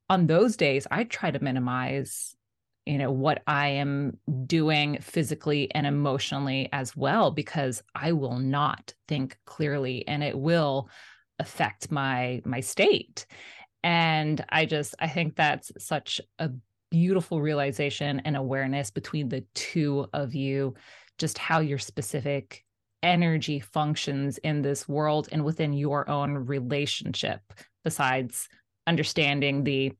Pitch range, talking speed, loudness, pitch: 135-155 Hz, 130 wpm, -27 LUFS, 145 Hz